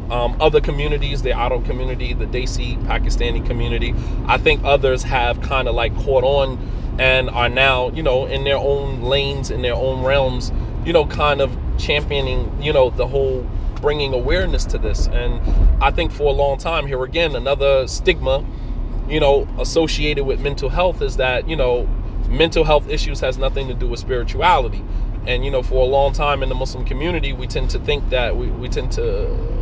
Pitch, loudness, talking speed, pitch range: 130 Hz, -19 LUFS, 190 wpm, 120-140 Hz